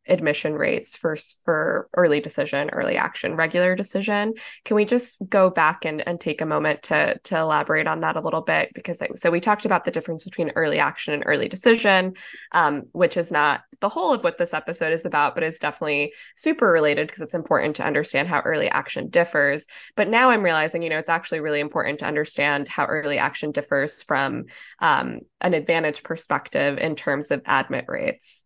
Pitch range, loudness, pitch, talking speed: 155-205 Hz, -22 LUFS, 170 Hz, 200 wpm